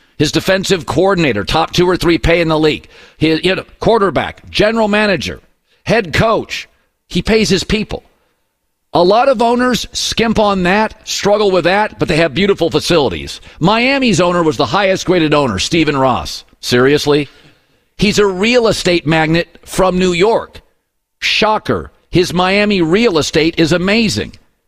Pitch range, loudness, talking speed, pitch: 155-205 Hz, -13 LUFS, 155 wpm, 180 Hz